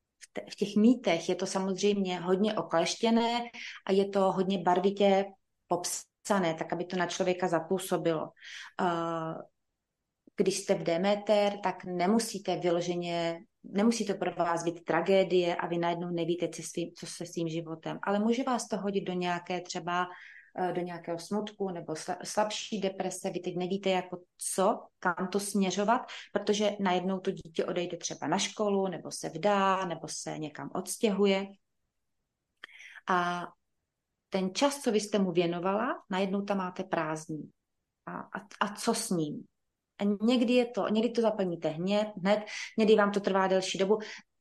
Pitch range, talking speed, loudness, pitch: 175-205 Hz, 155 wpm, -31 LUFS, 190 Hz